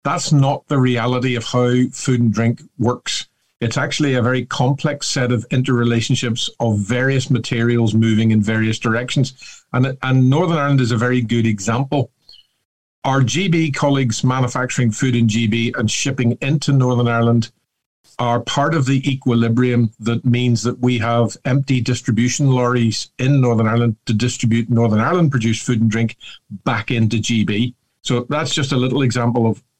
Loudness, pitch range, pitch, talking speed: -17 LUFS, 115-130 Hz, 125 Hz, 160 wpm